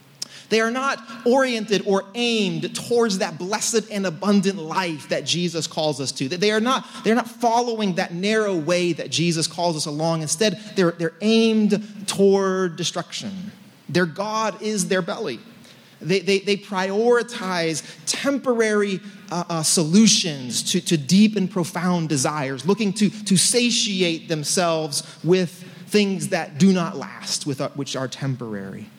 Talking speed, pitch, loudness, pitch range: 145 wpm, 190 Hz, -21 LUFS, 165-210 Hz